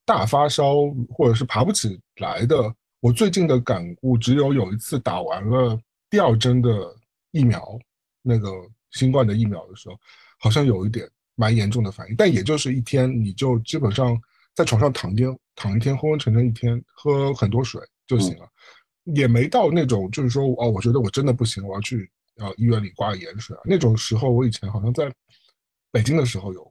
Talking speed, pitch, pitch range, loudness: 290 characters per minute, 120 Hz, 110-130 Hz, -21 LUFS